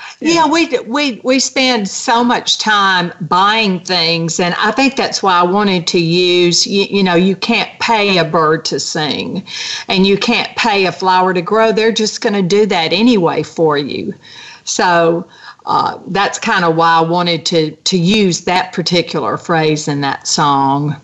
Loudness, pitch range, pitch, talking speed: -13 LUFS, 165-220 Hz, 185 Hz, 175 wpm